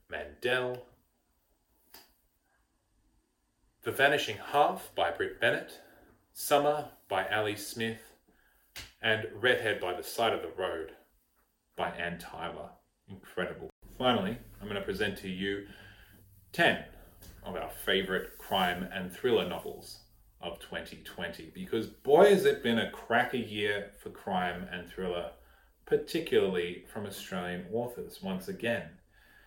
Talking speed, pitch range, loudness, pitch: 120 wpm, 90-115 Hz, -31 LUFS, 100 Hz